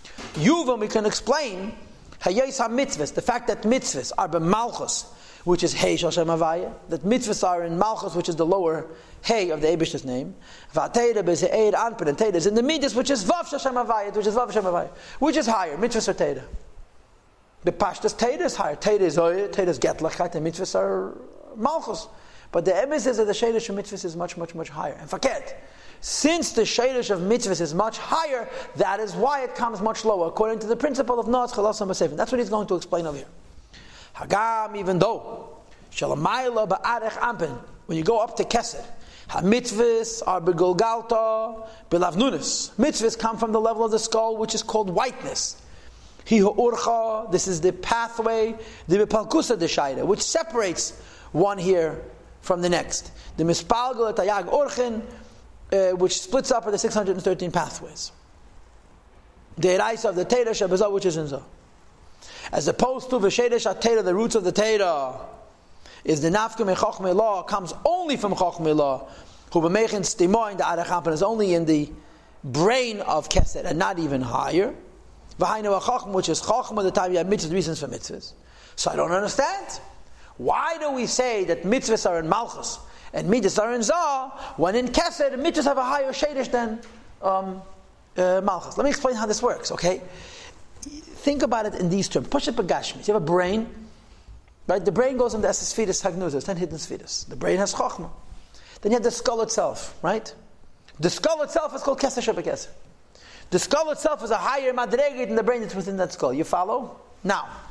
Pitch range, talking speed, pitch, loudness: 180-240 Hz, 180 wpm, 215 Hz, -24 LUFS